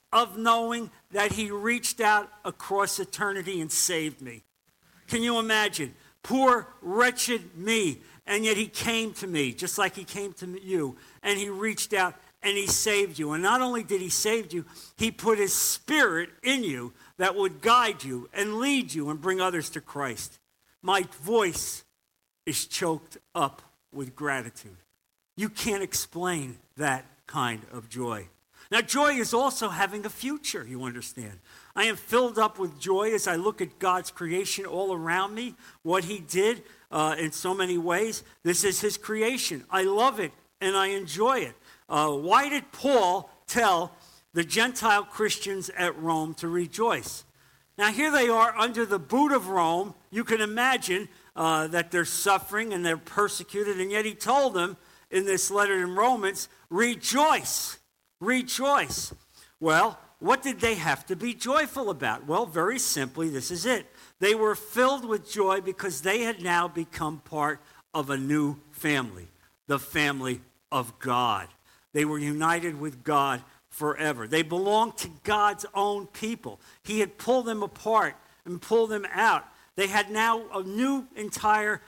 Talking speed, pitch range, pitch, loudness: 165 wpm, 160-220 Hz, 195 Hz, -27 LUFS